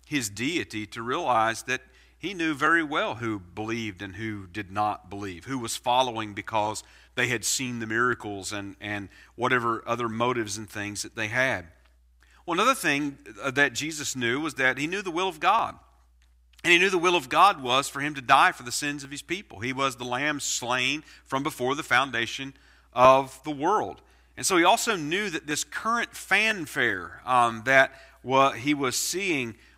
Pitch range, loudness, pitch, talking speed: 105-140 Hz, -25 LUFS, 125 Hz, 190 wpm